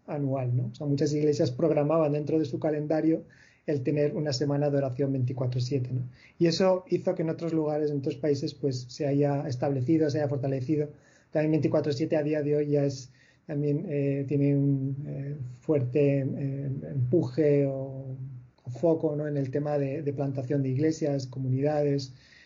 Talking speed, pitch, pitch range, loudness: 175 wpm, 145 Hz, 135-155 Hz, -28 LUFS